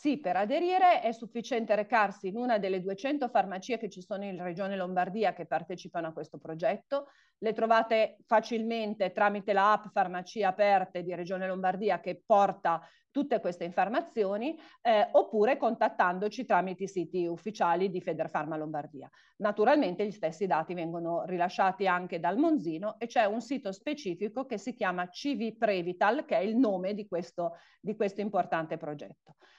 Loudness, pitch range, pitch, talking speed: -30 LUFS, 180-225 Hz, 200 Hz, 155 wpm